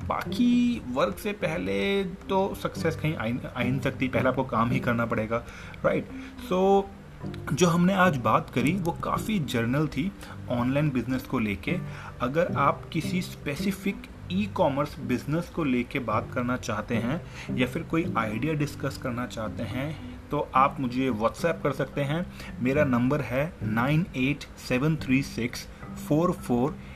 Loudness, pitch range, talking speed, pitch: -27 LUFS, 120-165 Hz, 160 wpm, 135 Hz